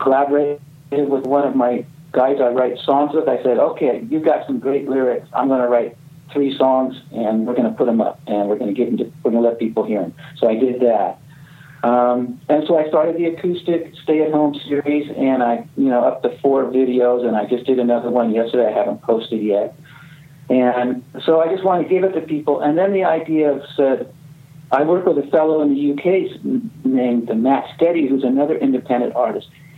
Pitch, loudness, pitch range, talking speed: 140 Hz, -18 LUFS, 125-155 Hz, 215 wpm